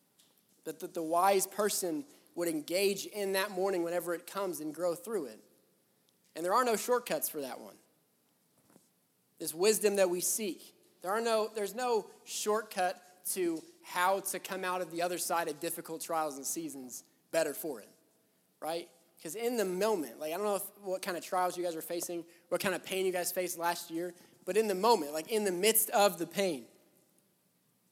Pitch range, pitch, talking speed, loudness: 170-205 Hz, 185 Hz, 195 wpm, -33 LUFS